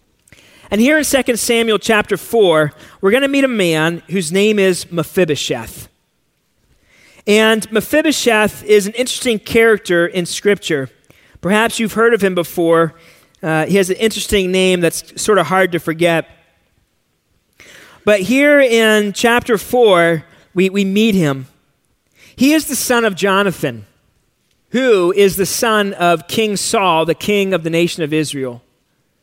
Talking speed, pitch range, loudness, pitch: 150 wpm, 165-220 Hz, -14 LUFS, 195 Hz